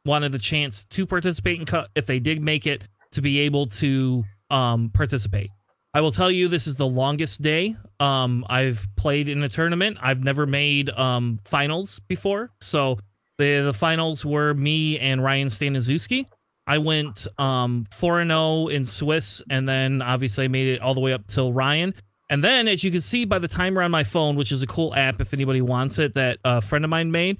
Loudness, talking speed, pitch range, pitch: -22 LUFS, 205 wpm, 130-155 Hz, 140 Hz